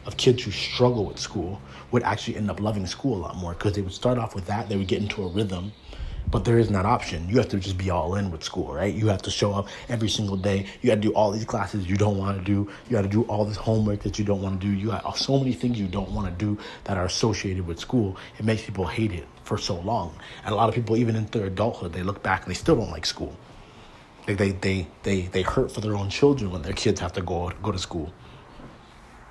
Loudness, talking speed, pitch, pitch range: -26 LUFS, 280 wpm, 100 Hz, 95-110 Hz